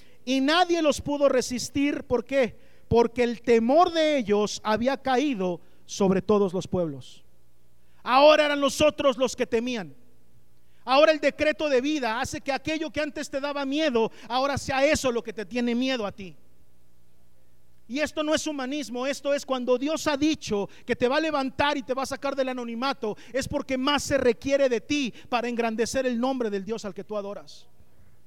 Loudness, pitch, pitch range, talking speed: -25 LUFS, 255 Hz, 210-285 Hz, 185 wpm